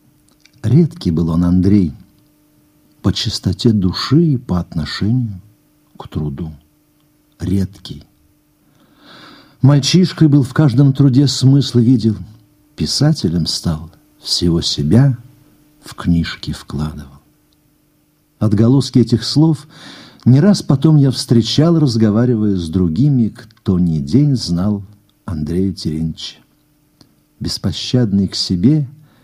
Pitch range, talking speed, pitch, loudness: 90-140 Hz, 95 wpm, 115 Hz, -15 LUFS